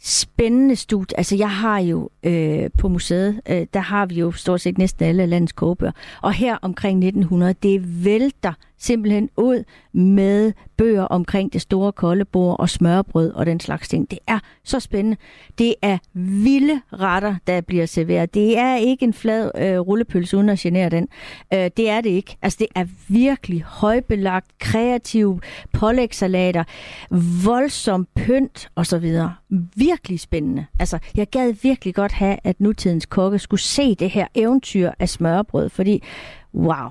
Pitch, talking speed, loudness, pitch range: 195 Hz, 160 wpm, -19 LUFS, 180-220 Hz